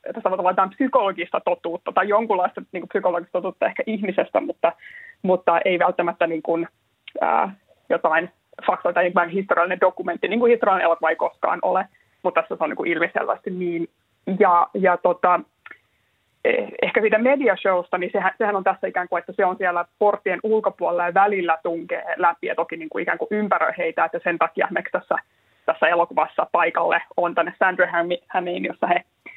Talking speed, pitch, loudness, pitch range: 175 wpm, 185 Hz, -21 LUFS, 175-200 Hz